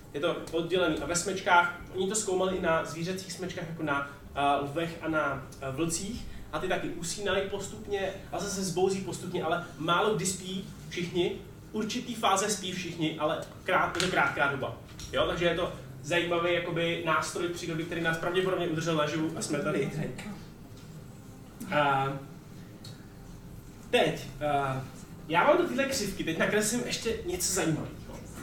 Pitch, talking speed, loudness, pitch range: 170 Hz, 150 wpm, -30 LUFS, 155-185 Hz